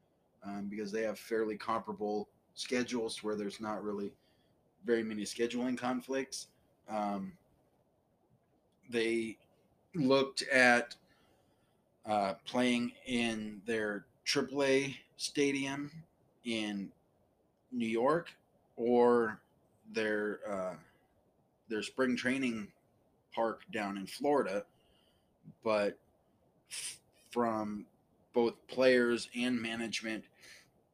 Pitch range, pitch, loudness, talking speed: 105-125 Hz, 115 Hz, -34 LUFS, 85 wpm